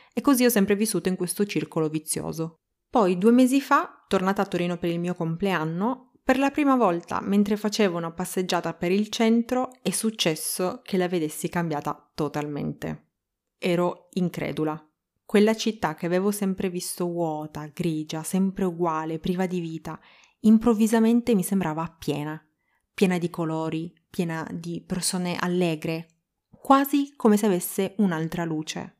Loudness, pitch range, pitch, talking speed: -25 LUFS, 165-210 Hz, 180 Hz, 145 wpm